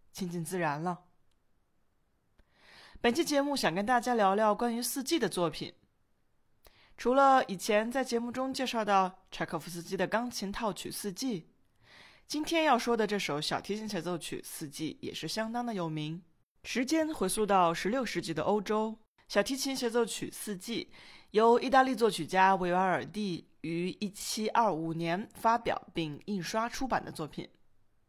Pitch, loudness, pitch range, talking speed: 200 Hz, -31 LUFS, 170-235 Hz, 245 characters per minute